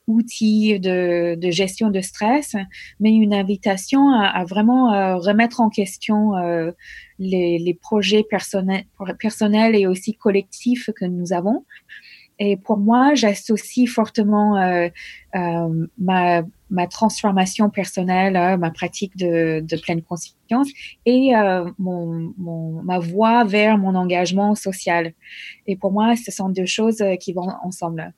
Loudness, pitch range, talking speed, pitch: -19 LUFS, 180-215 Hz, 140 wpm, 195 Hz